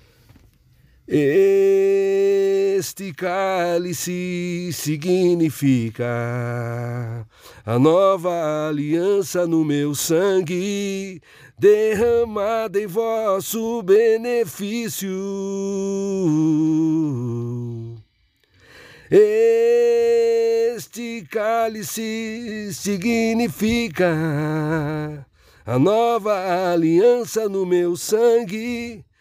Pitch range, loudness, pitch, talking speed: 155-225 Hz, -20 LUFS, 195 Hz, 45 wpm